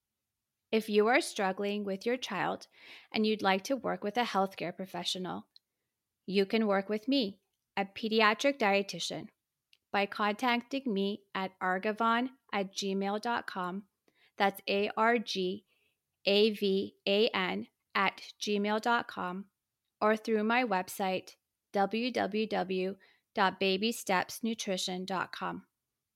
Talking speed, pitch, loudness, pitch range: 105 wpm, 200 Hz, -32 LUFS, 190-225 Hz